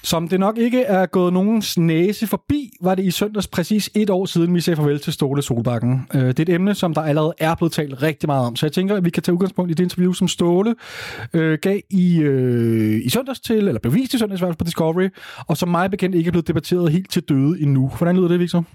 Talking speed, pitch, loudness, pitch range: 250 wpm, 175 Hz, -19 LUFS, 155-190 Hz